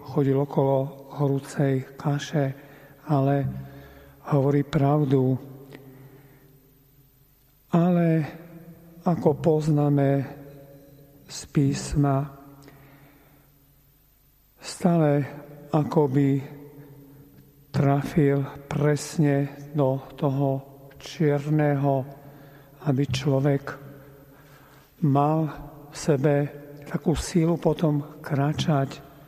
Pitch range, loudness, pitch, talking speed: 140-145 Hz, -24 LUFS, 140 Hz, 60 wpm